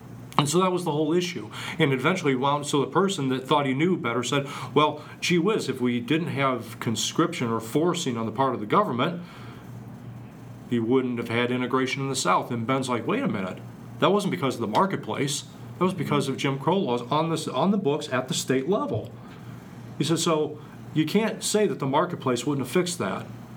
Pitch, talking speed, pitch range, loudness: 140 Hz, 215 wpm, 130-160 Hz, -25 LUFS